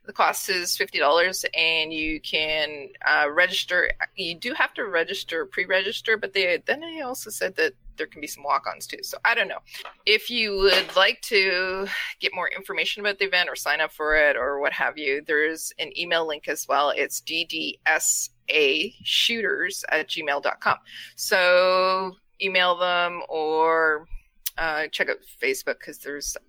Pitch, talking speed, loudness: 185 Hz, 160 wpm, -23 LUFS